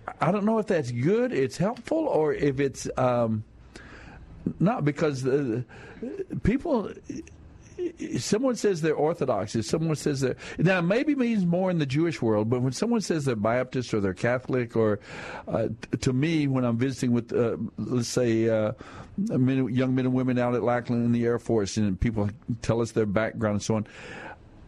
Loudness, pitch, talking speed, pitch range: -26 LUFS, 130 Hz, 190 wpm, 115-155 Hz